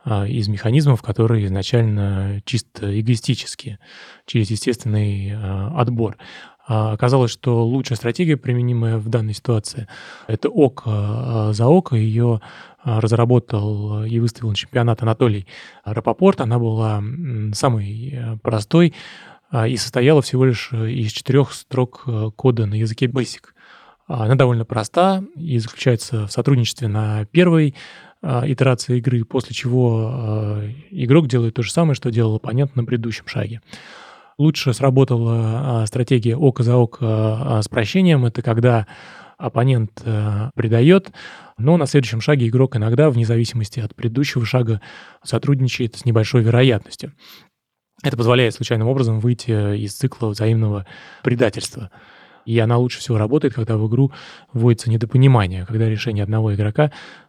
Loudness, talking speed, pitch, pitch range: -19 LUFS, 125 wpm, 120 Hz, 110-130 Hz